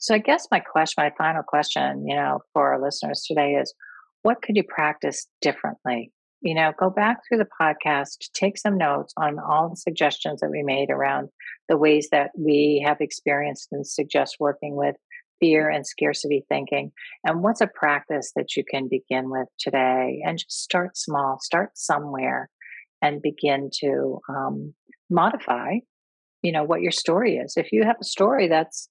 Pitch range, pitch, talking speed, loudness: 140-170 Hz, 150 Hz, 175 wpm, -23 LUFS